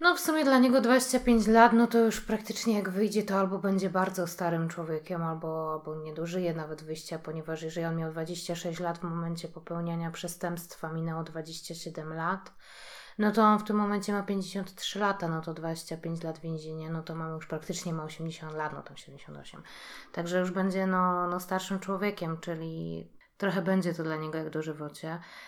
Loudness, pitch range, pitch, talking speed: -30 LUFS, 160-195 Hz, 170 Hz, 180 wpm